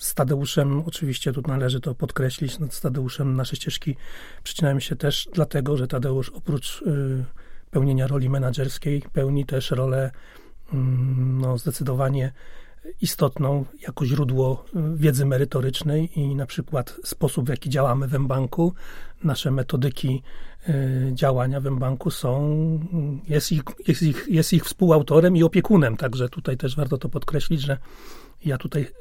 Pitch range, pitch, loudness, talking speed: 130-155 Hz, 140 Hz, -23 LUFS, 140 wpm